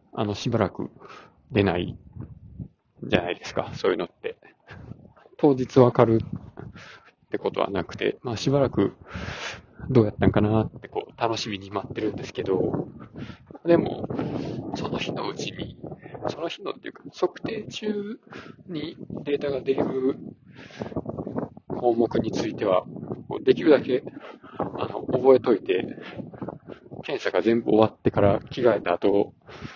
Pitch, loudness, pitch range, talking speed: 120 Hz, -25 LUFS, 105-135 Hz, 260 characters per minute